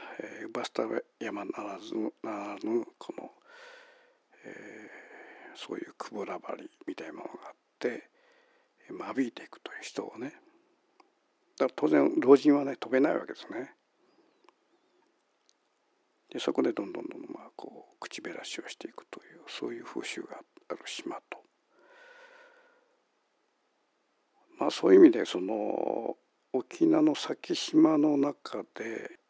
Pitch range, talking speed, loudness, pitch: 325-485 Hz, 260 characters per minute, -30 LUFS, 370 Hz